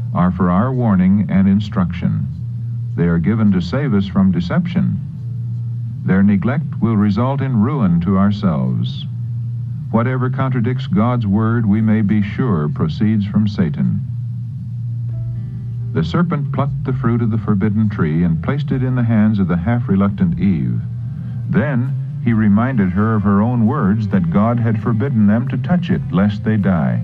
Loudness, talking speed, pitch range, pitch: -17 LUFS, 160 wpm, 105-130 Hz, 120 Hz